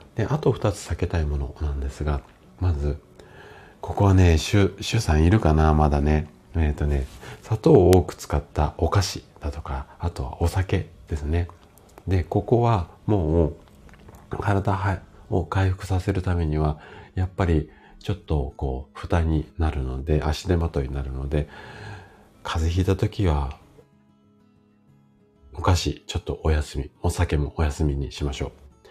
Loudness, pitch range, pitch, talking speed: -24 LUFS, 75-95 Hz, 85 Hz, 270 characters per minute